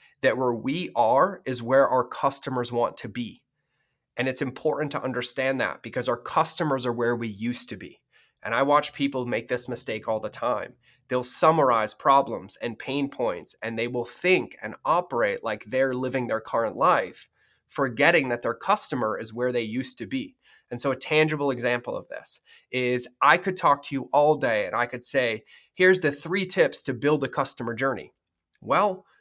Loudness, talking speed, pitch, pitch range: -25 LUFS, 190 wpm, 130 Hz, 125-145 Hz